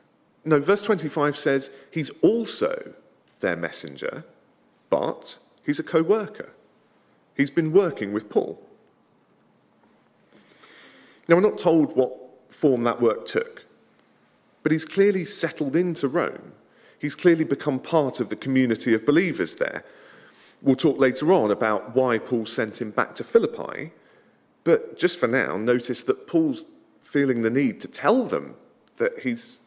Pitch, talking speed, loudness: 155 Hz, 140 wpm, -24 LUFS